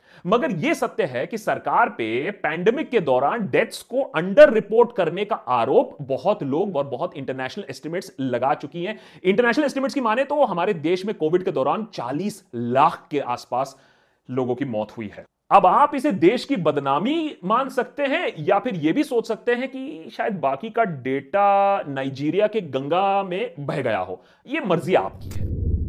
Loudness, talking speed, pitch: -22 LUFS, 180 wpm, 190 Hz